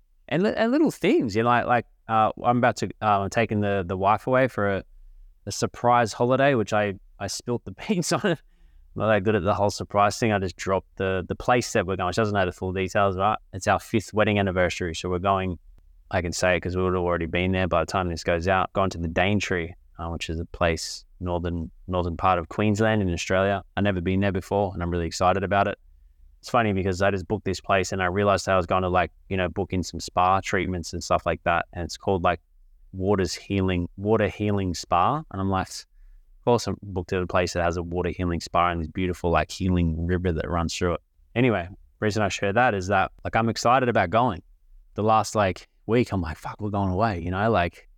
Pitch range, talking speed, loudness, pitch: 90-105 Hz, 245 wpm, -24 LUFS, 95 Hz